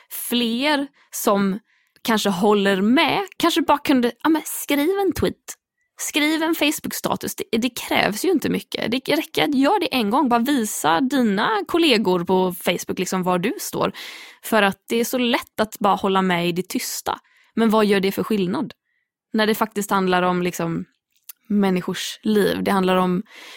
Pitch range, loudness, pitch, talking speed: 195-295 Hz, -20 LUFS, 225 Hz, 175 wpm